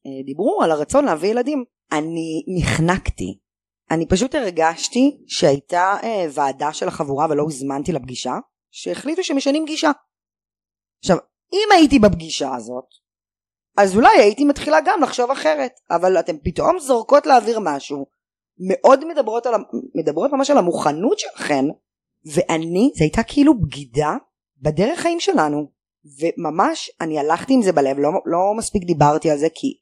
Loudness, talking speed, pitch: -18 LUFS, 135 wpm, 180 Hz